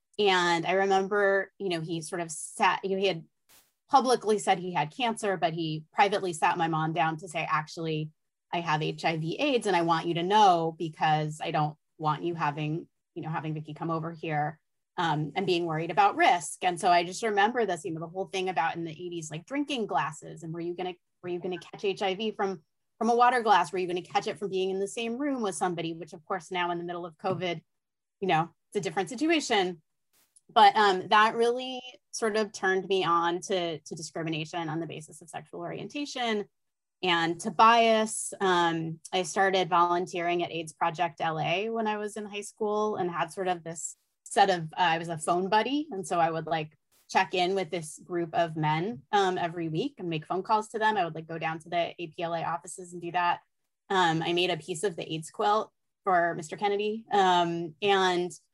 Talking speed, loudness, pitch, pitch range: 215 wpm, -28 LUFS, 180 Hz, 165-200 Hz